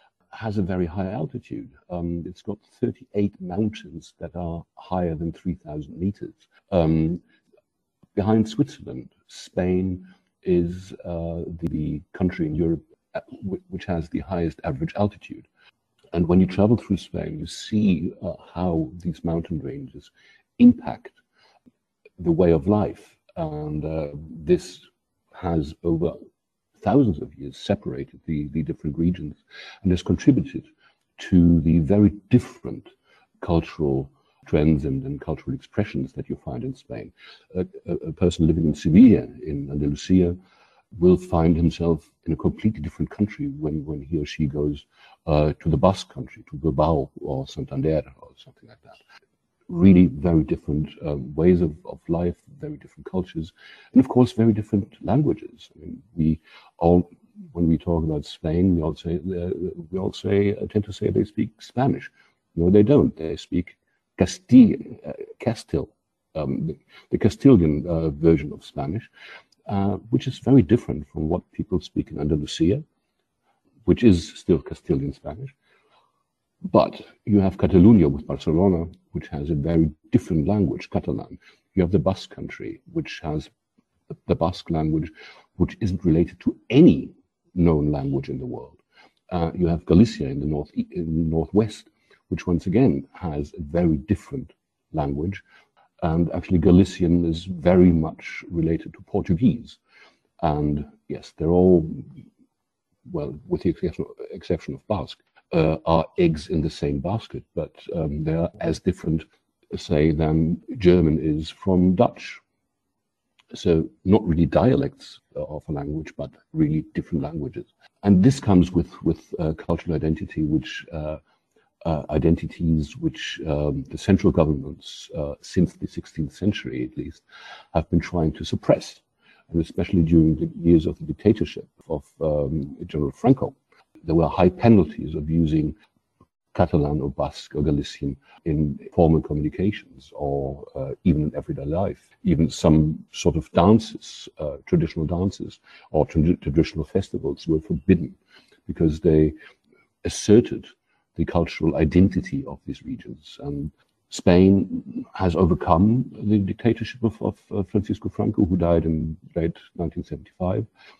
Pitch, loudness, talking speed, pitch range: 85 Hz, -23 LUFS, 145 wpm, 80-100 Hz